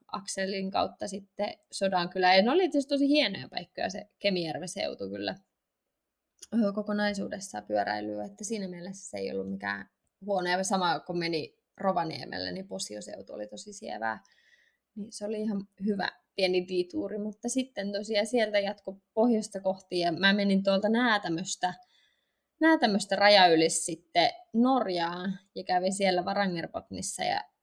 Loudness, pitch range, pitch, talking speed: -29 LUFS, 170-210 Hz, 195 Hz, 140 wpm